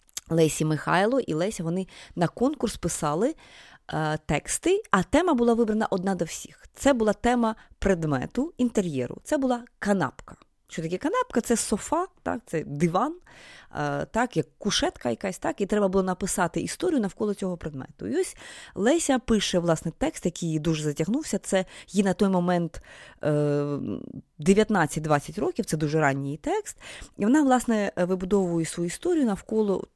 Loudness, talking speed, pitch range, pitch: -26 LUFS, 155 wpm, 165-235 Hz, 195 Hz